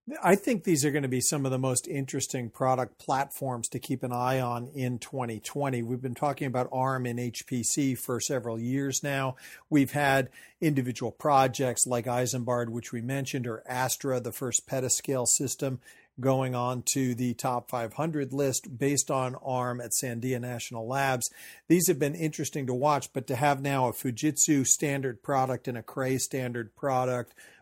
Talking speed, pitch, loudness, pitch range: 175 wpm, 130 Hz, -29 LUFS, 125-140 Hz